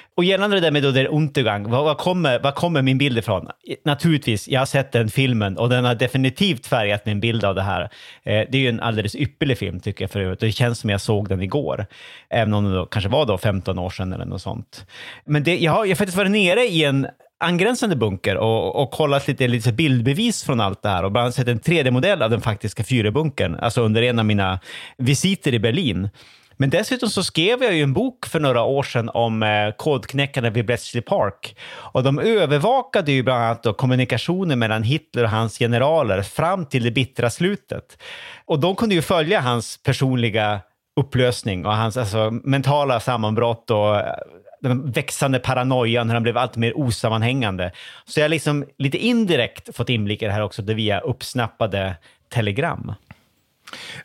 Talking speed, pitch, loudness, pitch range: 195 wpm, 125 Hz, -20 LUFS, 110-145 Hz